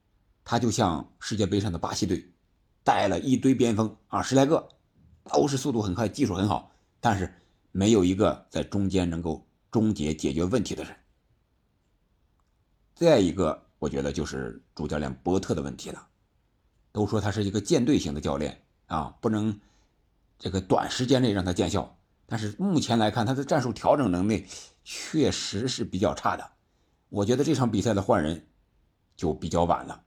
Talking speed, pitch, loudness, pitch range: 255 characters per minute, 100 Hz, -27 LUFS, 90-115 Hz